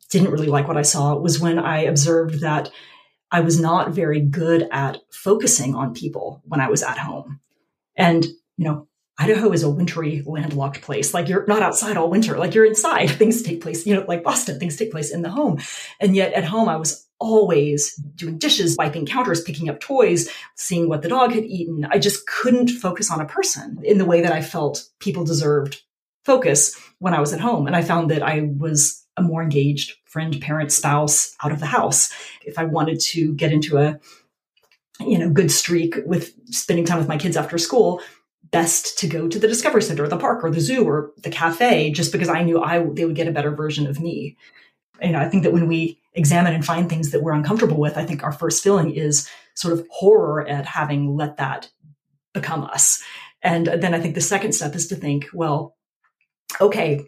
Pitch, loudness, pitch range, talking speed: 165 Hz, -19 LUFS, 150-180 Hz, 210 wpm